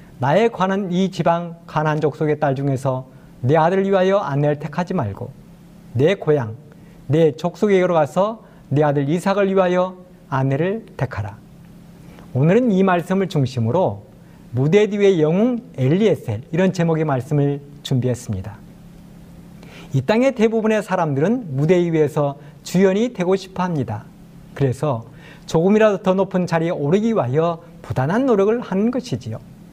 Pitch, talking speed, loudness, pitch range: 170 Hz, 300 characters per minute, -19 LUFS, 145-185 Hz